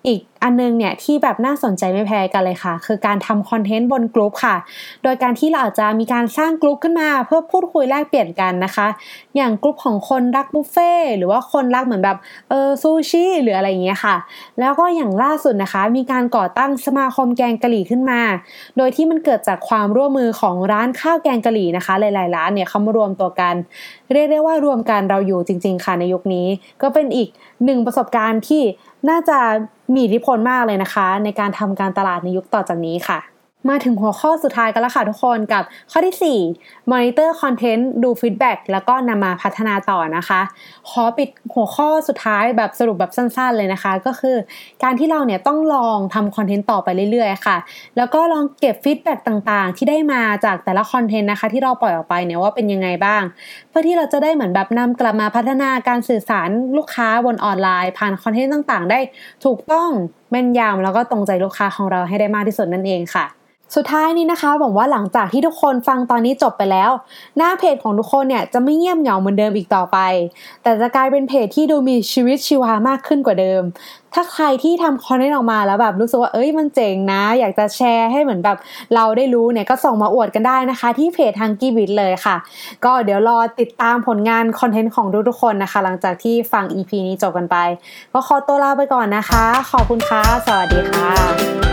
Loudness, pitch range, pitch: -16 LUFS, 205-275 Hz, 235 Hz